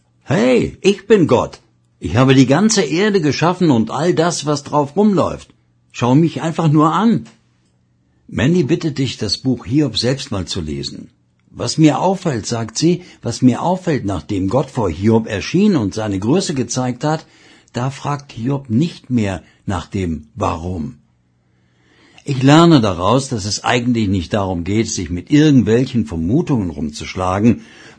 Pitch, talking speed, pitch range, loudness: 120 Hz, 150 wpm, 95-150 Hz, -16 LUFS